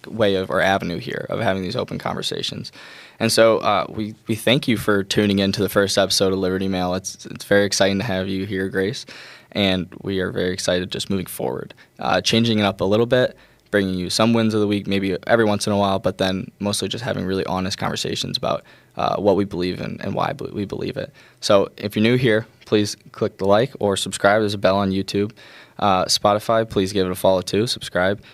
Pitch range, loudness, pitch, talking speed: 95-105 Hz, -20 LUFS, 100 Hz, 230 wpm